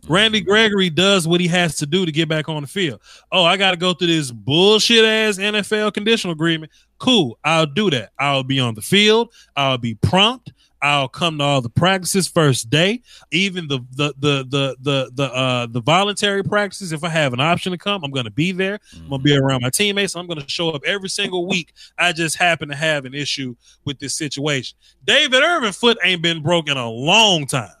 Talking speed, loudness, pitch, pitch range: 220 wpm, -17 LUFS, 165 Hz, 140-195 Hz